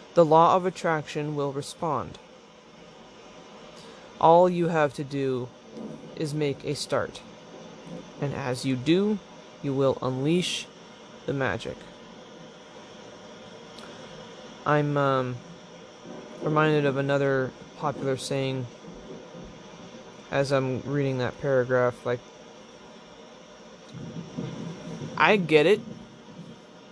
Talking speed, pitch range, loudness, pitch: 90 wpm, 130-155 Hz, -26 LUFS, 140 Hz